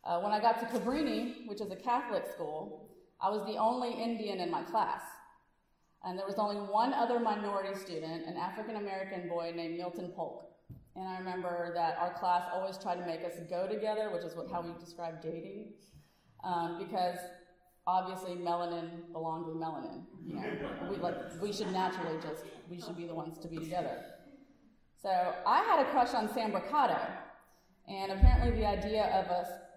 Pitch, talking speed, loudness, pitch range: 185 Hz, 180 wpm, -35 LUFS, 175-215 Hz